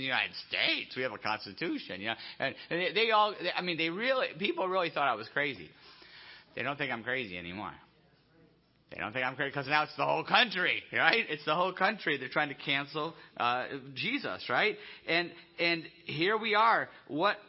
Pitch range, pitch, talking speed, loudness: 140-190 Hz, 165 Hz, 200 wpm, -31 LUFS